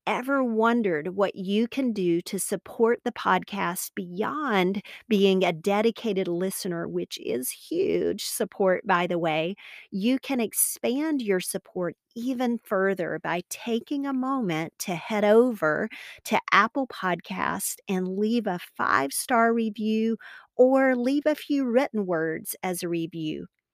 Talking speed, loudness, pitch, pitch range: 135 wpm, -26 LUFS, 210 Hz, 180-245 Hz